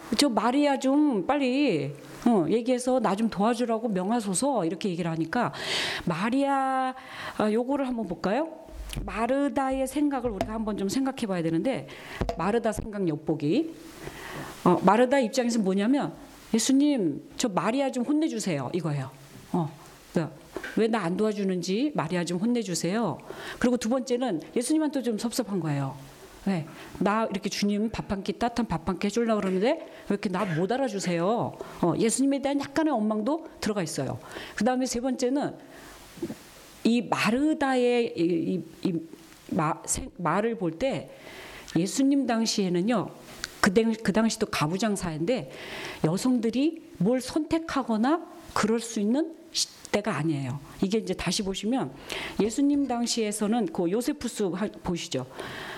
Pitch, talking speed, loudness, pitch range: 225 Hz, 305 characters per minute, -27 LUFS, 180-260 Hz